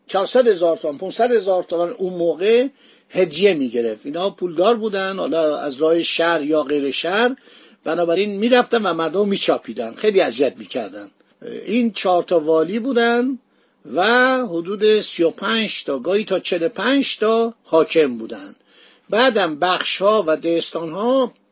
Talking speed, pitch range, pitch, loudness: 140 wpm, 165-230 Hz, 190 Hz, -18 LUFS